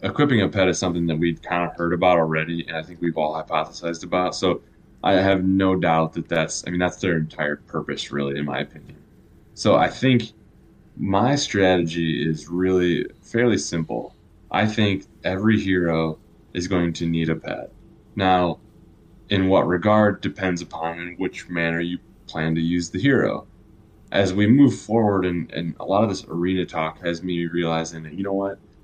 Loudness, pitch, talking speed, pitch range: -22 LUFS, 90 Hz, 185 wpm, 80-95 Hz